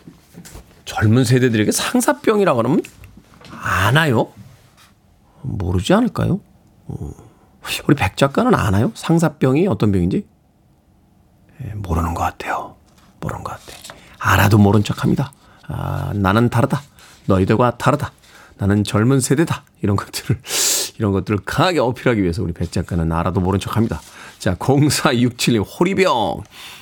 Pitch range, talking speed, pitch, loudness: 95-130 Hz, 280 characters per minute, 105 Hz, -18 LUFS